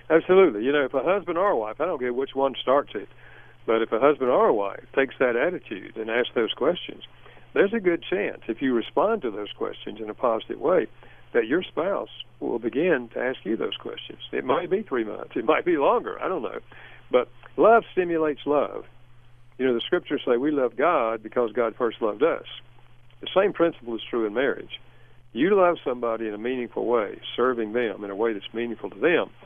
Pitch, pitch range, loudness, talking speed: 125 Hz, 115-175 Hz, -25 LUFS, 215 wpm